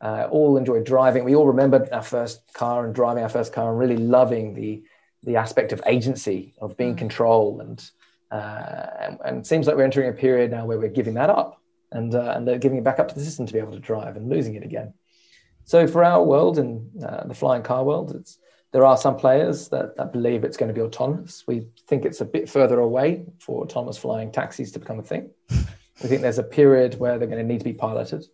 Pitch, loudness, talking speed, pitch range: 125 Hz, -21 LUFS, 245 wpm, 115-135 Hz